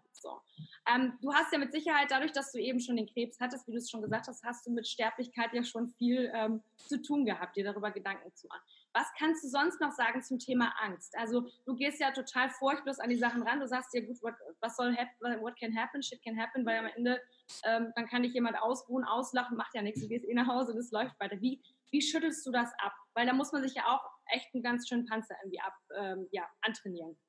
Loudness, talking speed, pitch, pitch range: -35 LUFS, 250 wpm, 240 Hz, 225-255 Hz